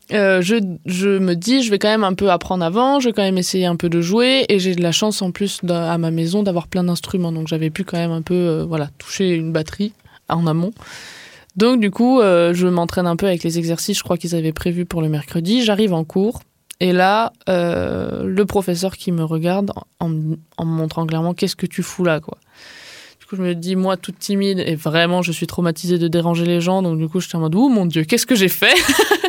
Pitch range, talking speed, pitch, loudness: 170-200 Hz, 250 wpm, 180 Hz, -18 LUFS